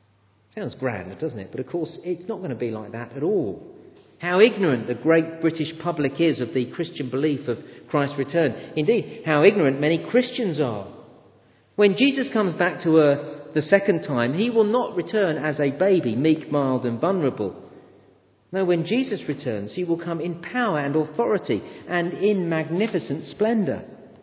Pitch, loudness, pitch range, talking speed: 165 Hz, -23 LUFS, 140-190 Hz, 175 wpm